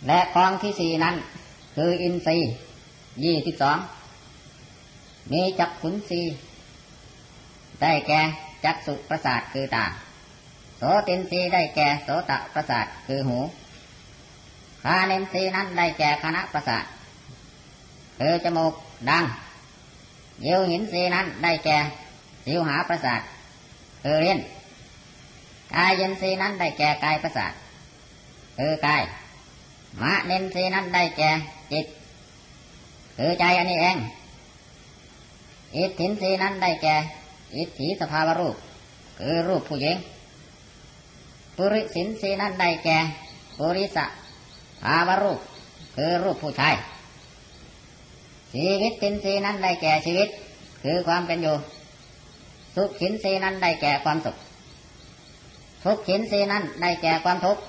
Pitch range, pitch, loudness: 150-185 Hz, 165 Hz, -24 LUFS